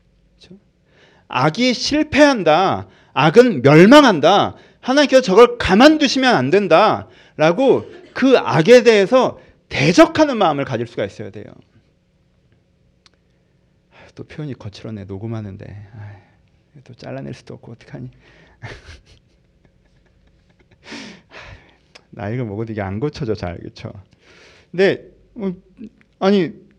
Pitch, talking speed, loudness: 170 Hz, 215 characters per minute, -14 LUFS